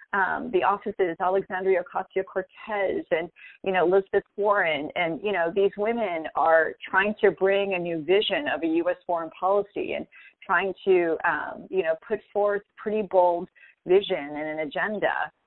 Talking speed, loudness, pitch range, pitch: 165 wpm, -25 LUFS, 180-210 Hz, 195 Hz